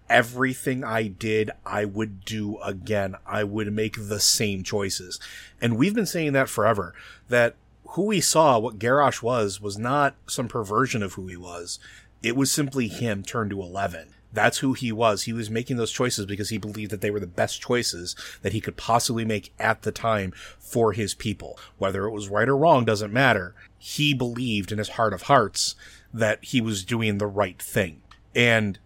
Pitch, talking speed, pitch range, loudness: 110 Hz, 195 wpm, 105-120 Hz, -24 LUFS